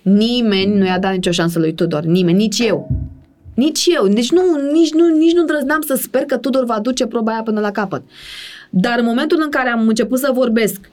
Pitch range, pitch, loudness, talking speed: 195-285 Hz, 235 Hz, -15 LUFS, 220 wpm